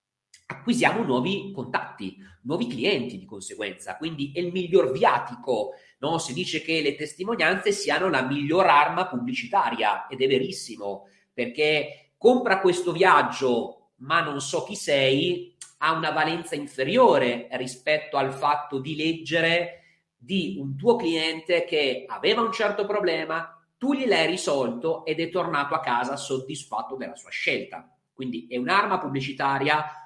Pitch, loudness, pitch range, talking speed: 160 Hz, -24 LUFS, 140-185 Hz, 140 wpm